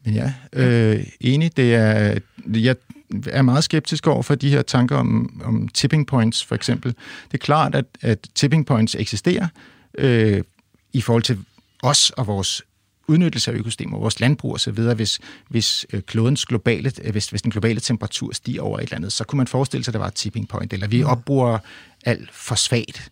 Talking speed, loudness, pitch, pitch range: 190 wpm, -20 LUFS, 120 Hz, 110-135 Hz